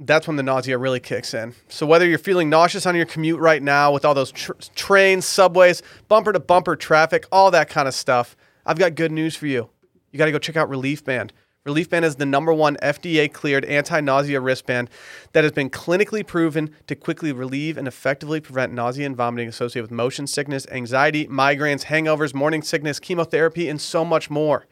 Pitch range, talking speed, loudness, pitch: 135-165 Hz, 205 wpm, -19 LUFS, 150 Hz